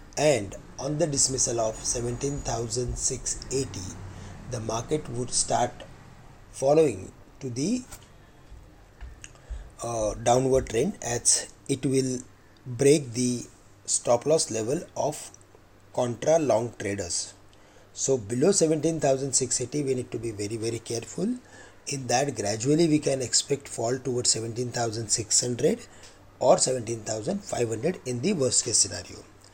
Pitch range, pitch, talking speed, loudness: 105-135 Hz, 120 Hz, 110 wpm, -26 LUFS